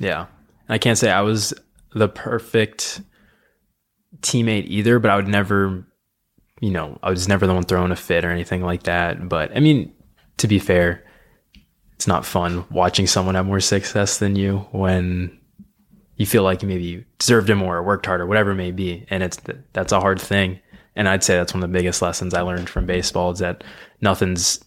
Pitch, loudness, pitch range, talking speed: 95 Hz, -20 LUFS, 90-105 Hz, 200 wpm